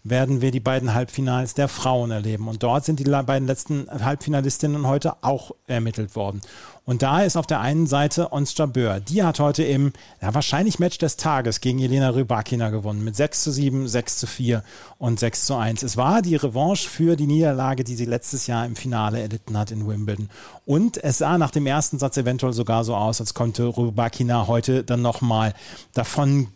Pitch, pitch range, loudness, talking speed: 130 Hz, 115-145 Hz, -22 LUFS, 200 wpm